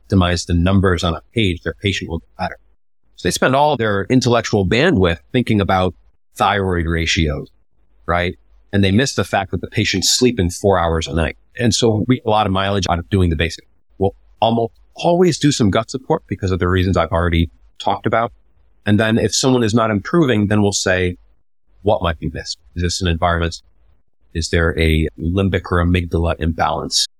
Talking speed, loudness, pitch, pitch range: 195 wpm, -17 LUFS, 95 Hz, 85-105 Hz